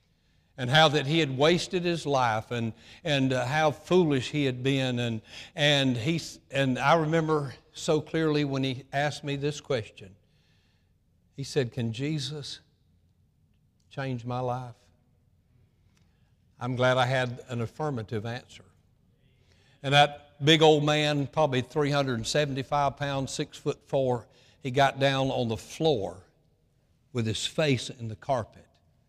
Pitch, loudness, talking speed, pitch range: 135 Hz, -27 LUFS, 140 wpm, 120-150 Hz